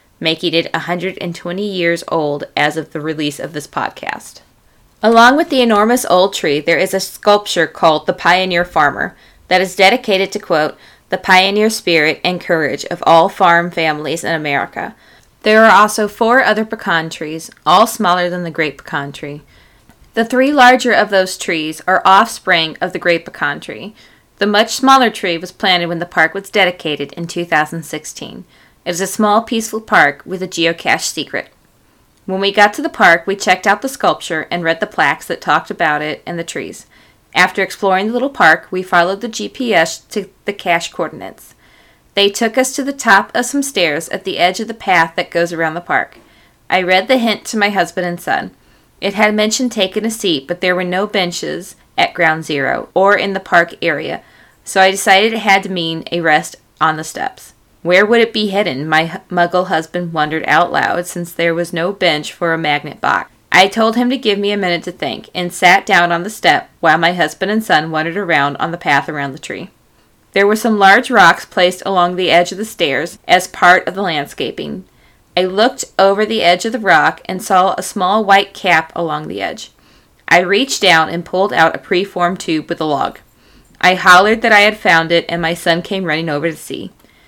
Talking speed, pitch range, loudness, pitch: 205 wpm, 165-205 Hz, -14 LUFS, 180 Hz